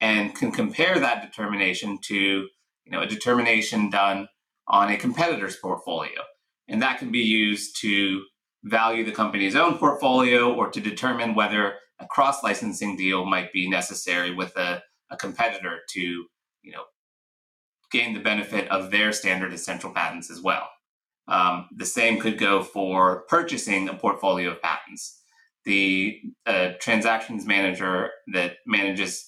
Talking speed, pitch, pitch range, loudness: 145 wpm, 100 Hz, 95-110 Hz, -23 LUFS